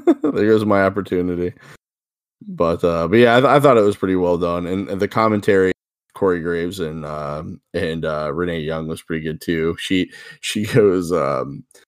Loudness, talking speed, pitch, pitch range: -18 LUFS, 180 wpm, 90 Hz, 80-100 Hz